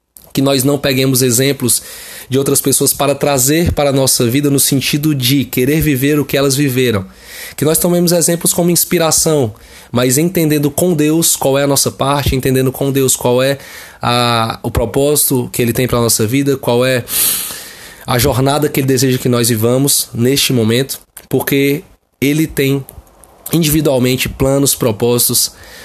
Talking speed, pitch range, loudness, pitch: 165 wpm, 125-145 Hz, -13 LUFS, 135 Hz